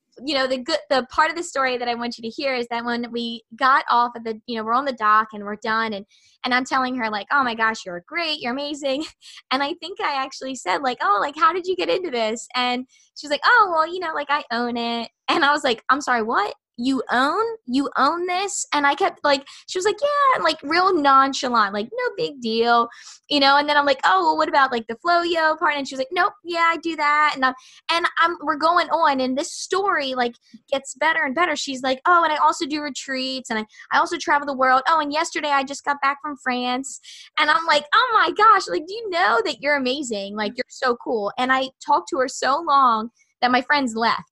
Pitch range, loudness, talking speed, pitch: 245-320 Hz, -21 LUFS, 260 wpm, 275 Hz